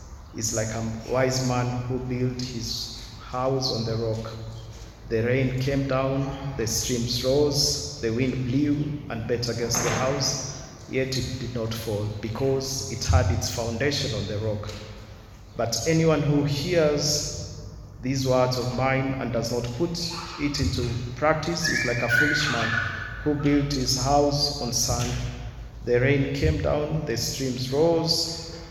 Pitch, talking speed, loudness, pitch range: 125 Hz, 155 wpm, -25 LUFS, 115-140 Hz